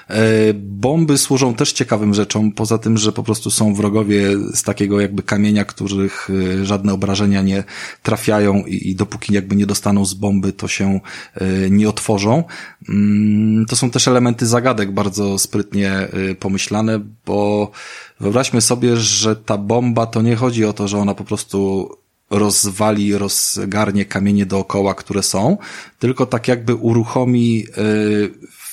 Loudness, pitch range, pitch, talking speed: -16 LUFS, 100-110 Hz, 105 Hz, 135 wpm